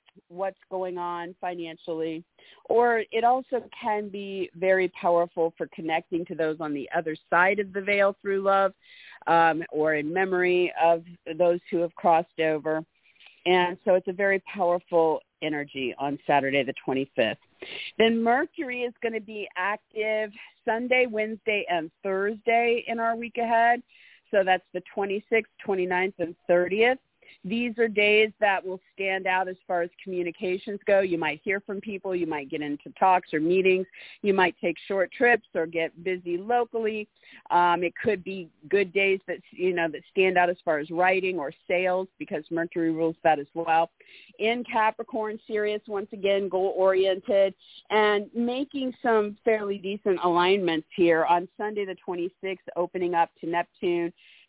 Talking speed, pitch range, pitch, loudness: 160 wpm, 170-210 Hz, 185 Hz, -26 LUFS